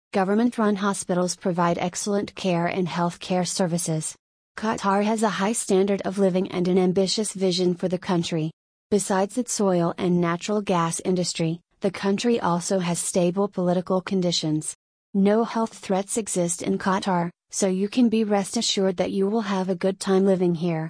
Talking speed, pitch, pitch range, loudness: 170 wpm, 190 Hz, 175-200 Hz, -24 LUFS